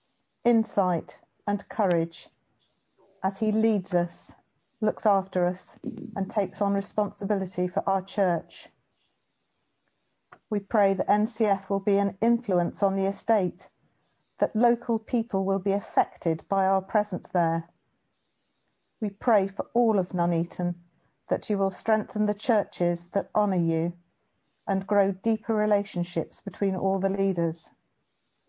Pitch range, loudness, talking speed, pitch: 180-210 Hz, -27 LUFS, 130 wpm, 195 Hz